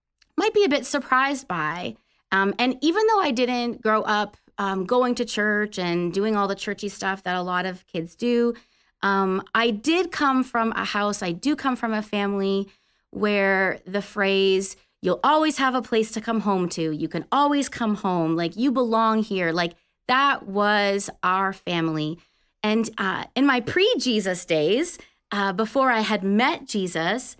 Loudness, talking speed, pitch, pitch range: -23 LUFS, 180 wpm, 210 Hz, 190-250 Hz